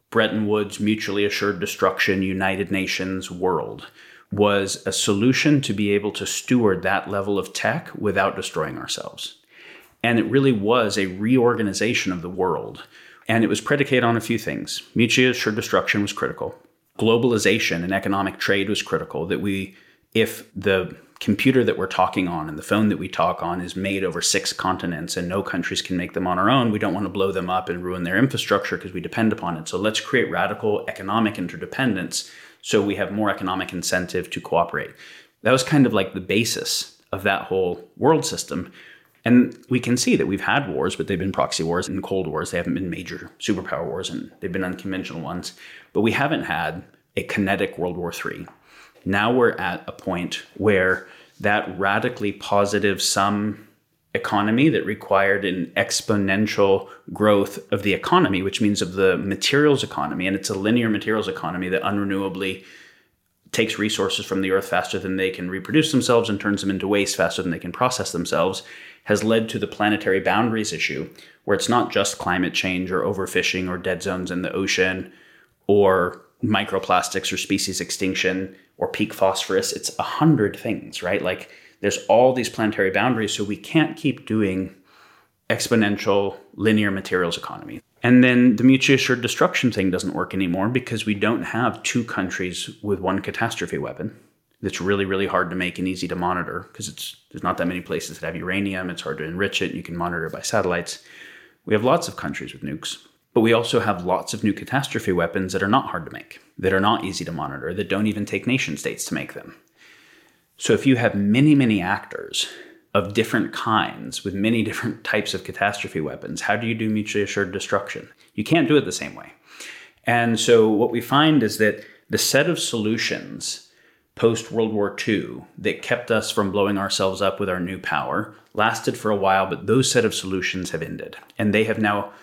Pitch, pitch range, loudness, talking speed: 100 Hz, 95-115 Hz, -22 LUFS, 190 wpm